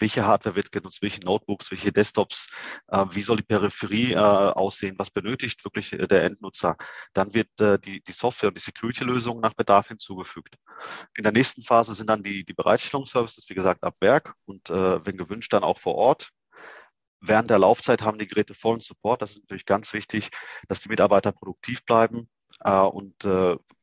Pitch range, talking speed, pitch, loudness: 100-110 Hz, 185 wpm, 105 Hz, -24 LUFS